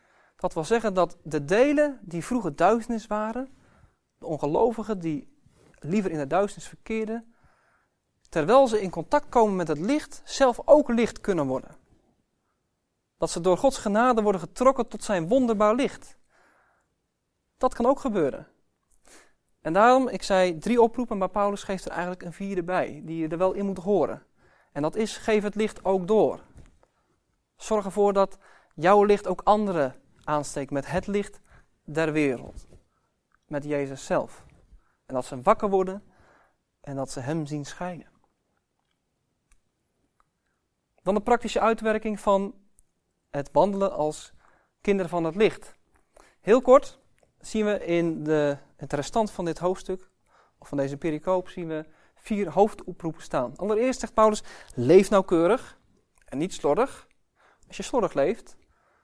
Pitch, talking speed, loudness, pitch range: 195 Hz, 145 wpm, -25 LUFS, 165-220 Hz